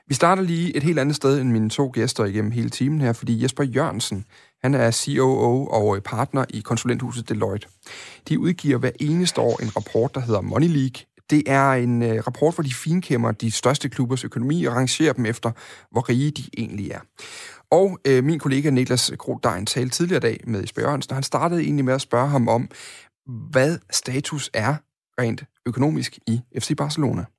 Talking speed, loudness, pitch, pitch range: 195 wpm, -22 LUFS, 130 Hz, 115-145 Hz